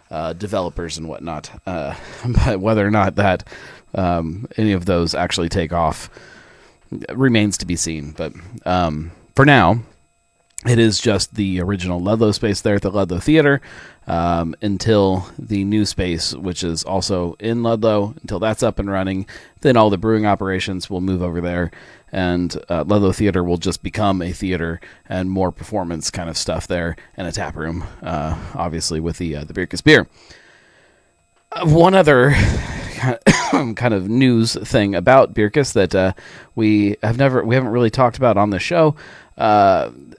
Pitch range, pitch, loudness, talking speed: 90-110 Hz, 100 Hz, -18 LUFS, 165 wpm